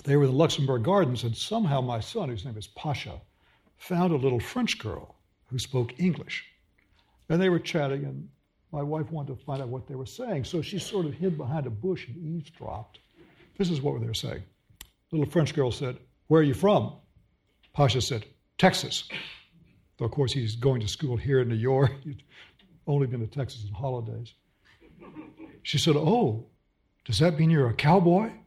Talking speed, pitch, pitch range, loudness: 195 wpm, 140 Hz, 115-165 Hz, -27 LUFS